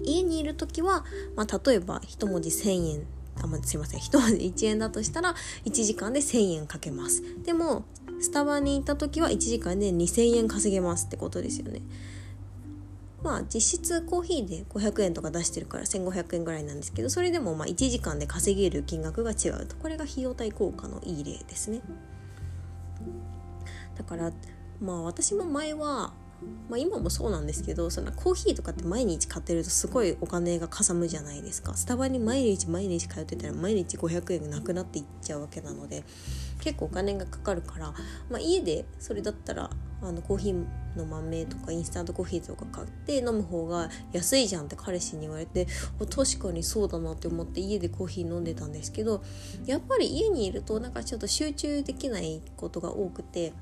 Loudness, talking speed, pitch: -30 LUFS, 375 characters per minute, 175 Hz